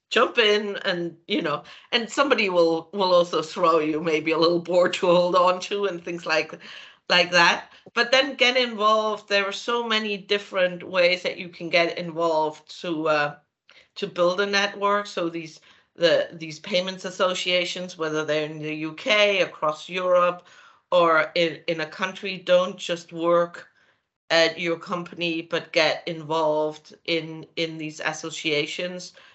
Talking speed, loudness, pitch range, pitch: 155 wpm, -23 LUFS, 160-190 Hz, 175 Hz